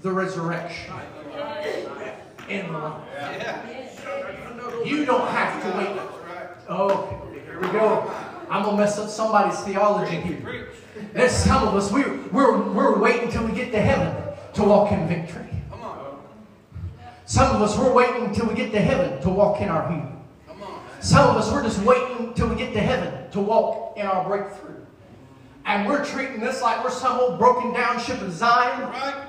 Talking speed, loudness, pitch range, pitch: 170 wpm, -22 LUFS, 195-245 Hz, 215 Hz